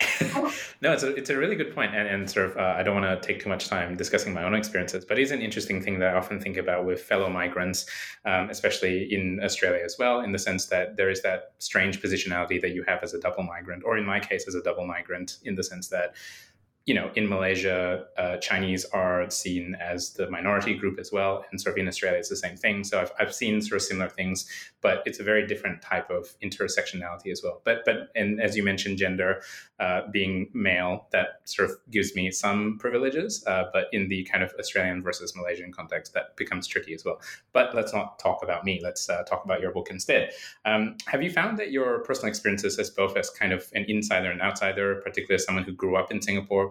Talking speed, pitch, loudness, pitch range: 235 wpm, 95 Hz, -27 LUFS, 90-100 Hz